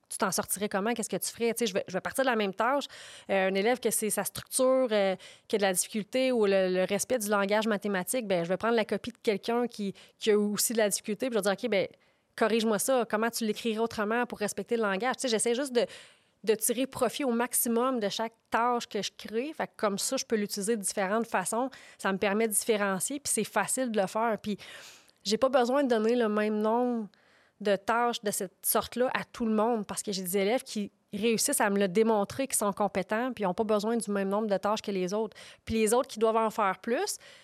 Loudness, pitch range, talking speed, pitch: -29 LUFS, 205-240 Hz, 255 wpm, 220 Hz